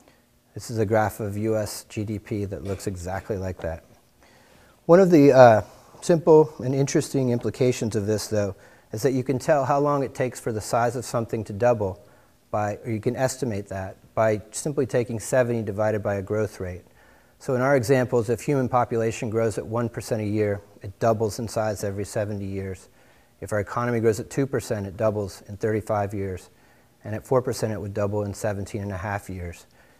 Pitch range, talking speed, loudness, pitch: 105-125 Hz, 190 wpm, -24 LUFS, 110 Hz